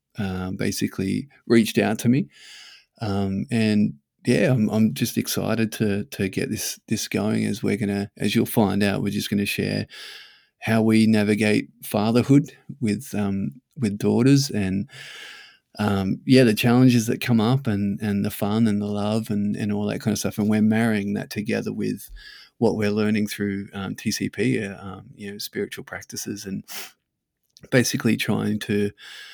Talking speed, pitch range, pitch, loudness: 170 wpm, 100-115 Hz, 105 Hz, -23 LUFS